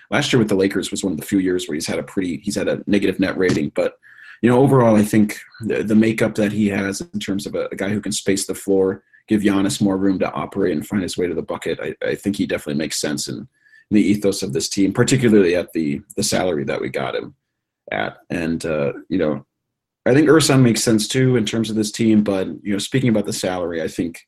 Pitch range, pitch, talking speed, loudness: 100-120 Hz, 105 Hz, 260 wpm, -19 LUFS